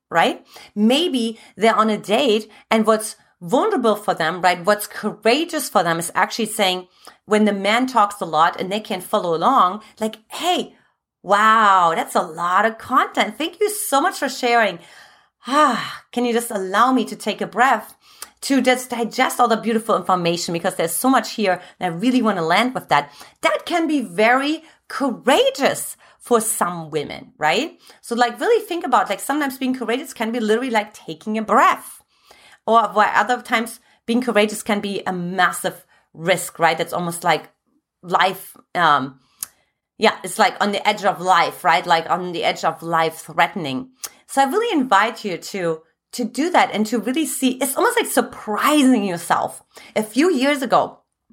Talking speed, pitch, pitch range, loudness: 180 wpm, 220 Hz, 185-255 Hz, -19 LUFS